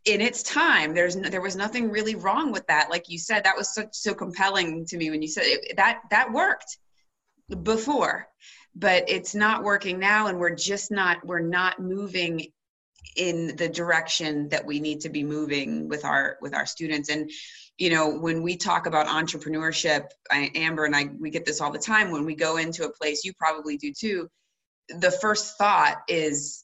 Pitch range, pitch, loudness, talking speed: 155-200 Hz, 170 Hz, -24 LUFS, 200 wpm